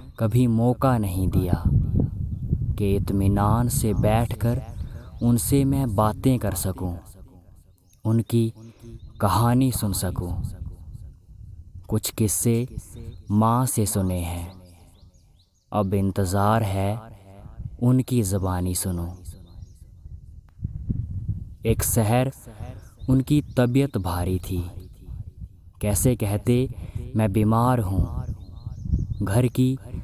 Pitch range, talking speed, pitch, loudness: 90-115 Hz, 85 wpm, 105 Hz, -23 LUFS